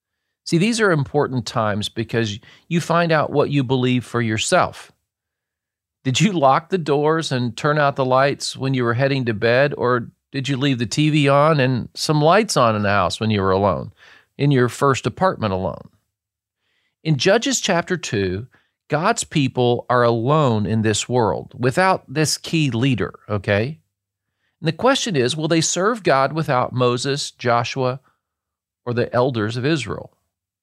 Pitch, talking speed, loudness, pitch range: 130 Hz, 165 wpm, -19 LUFS, 110-150 Hz